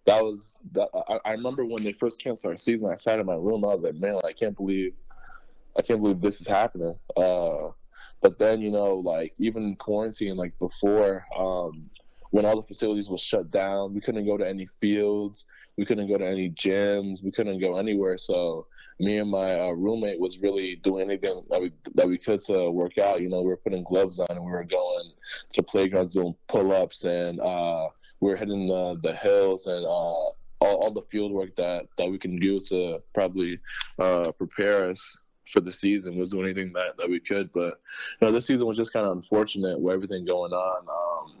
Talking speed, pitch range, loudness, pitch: 215 wpm, 90-105 Hz, -27 LUFS, 95 Hz